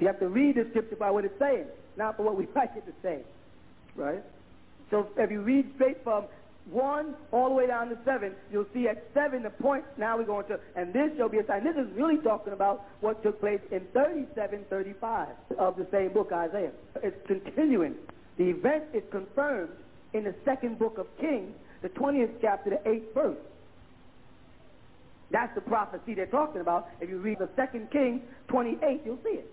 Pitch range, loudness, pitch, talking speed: 200-270 Hz, -30 LUFS, 220 Hz, 195 wpm